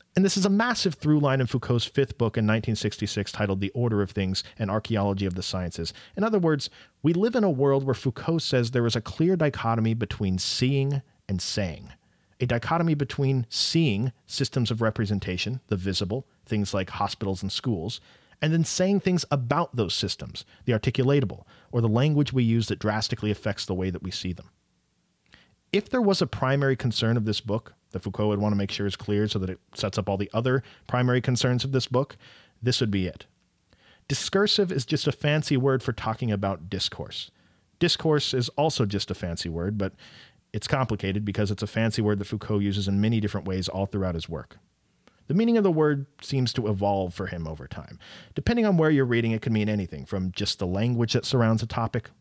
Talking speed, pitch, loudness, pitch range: 205 wpm, 115 Hz, -26 LUFS, 100-135 Hz